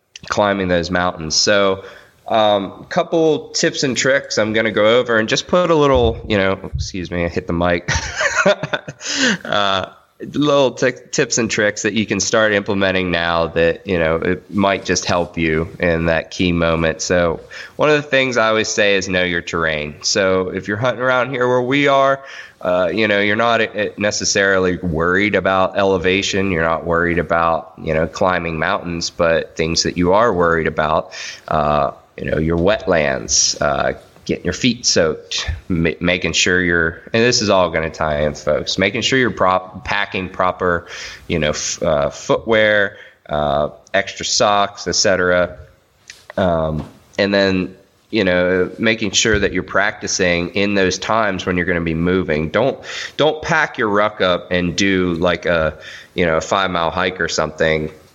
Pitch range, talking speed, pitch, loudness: 85-105 Hz, 175 wpm, 95 Hz, -17 LUFS